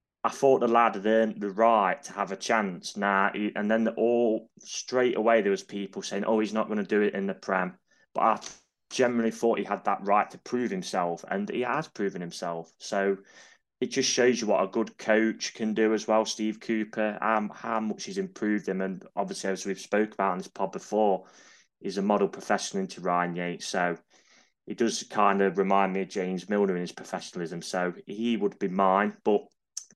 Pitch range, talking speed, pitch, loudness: 95-115 Hz, 210 wpm, 105 Hz, -28 LUFS